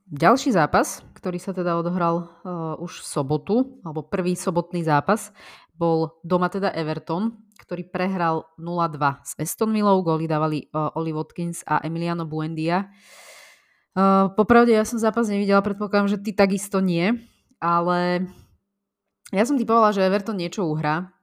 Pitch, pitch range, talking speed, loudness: 180 Hz, 165-200 Hz, 145 wpm, -23 LUFS